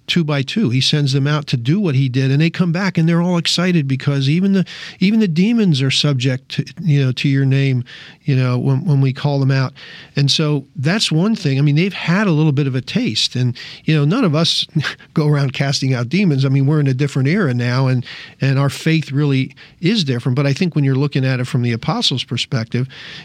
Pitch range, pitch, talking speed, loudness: 135-165 Hz, 145 Hz, 245 wpm, -16 LUFS